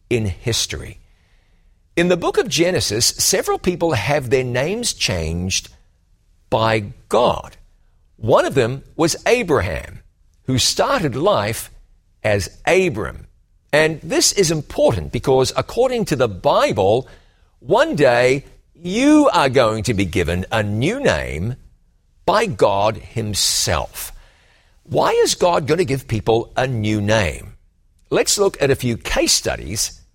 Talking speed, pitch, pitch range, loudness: 130 wpm, 115 Hz, 95-145 Hz, -18 LUFS